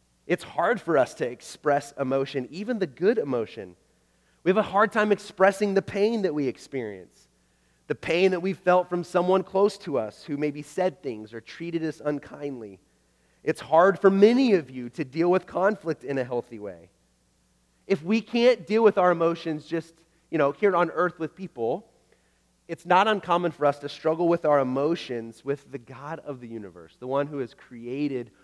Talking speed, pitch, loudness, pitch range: 190 wpm, 155 Hz, -25 LUFS, 130-185 Hz